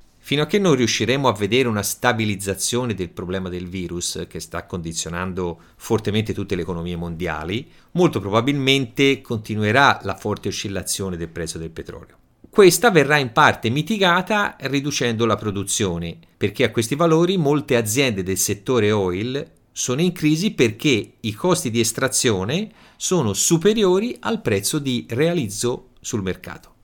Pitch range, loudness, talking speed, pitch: 95-145 Hz, -20 LUFS, 145 wpm, 120 Hz